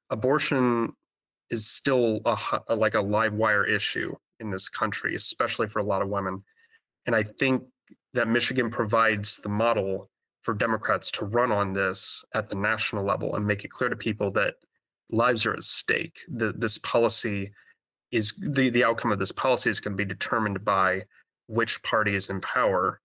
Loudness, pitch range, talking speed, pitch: -24 LUFS, 105-120 Hz, 180 wpm, 115 Hz